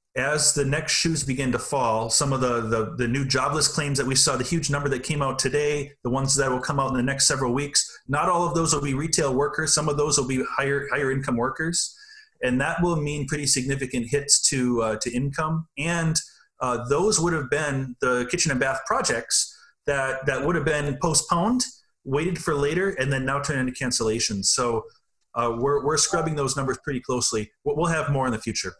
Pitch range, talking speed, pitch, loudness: 130-155 Hz, 220 wpm, 140 Hz, -23 LUFS